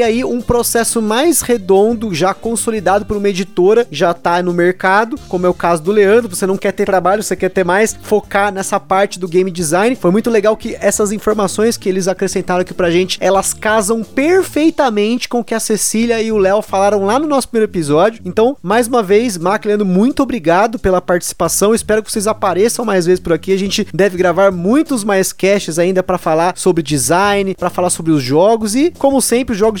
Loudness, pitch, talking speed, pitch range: -13 LUFS, 200 Hz, 210 wpm, 185-225 Hz